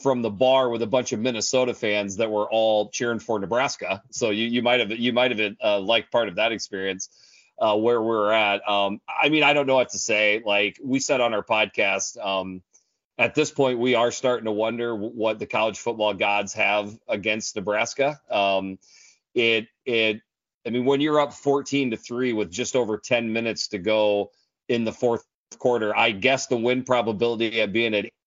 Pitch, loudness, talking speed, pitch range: 115 Hz, -23 LUFS, 210 wpm, 105-125 Hz